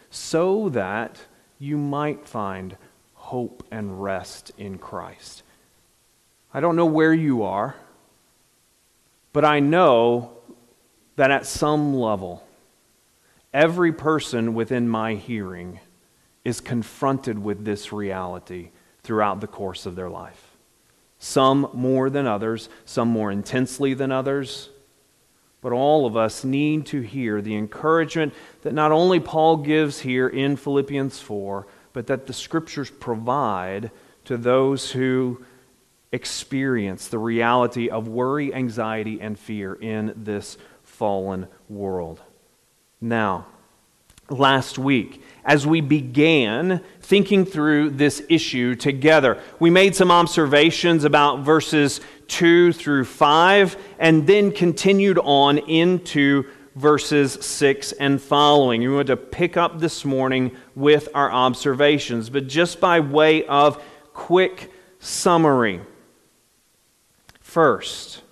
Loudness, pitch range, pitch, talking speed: -20 LUFS, 115-150 Hz, 135 Hz, 115 wpm